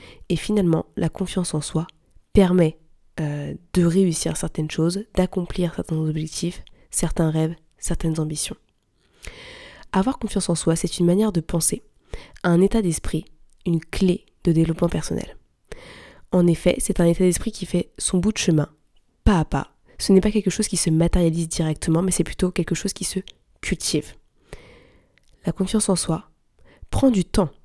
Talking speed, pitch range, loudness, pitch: 165 wpm, 165-195 Hz, -22 LUFS, 175 Hz